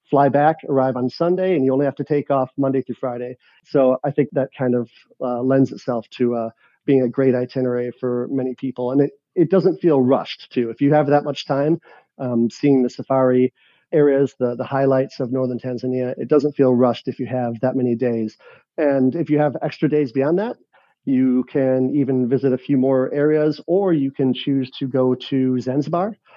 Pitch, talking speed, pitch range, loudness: 135 Hz, 205 wpm, 125-145 Hz, -19 LUFS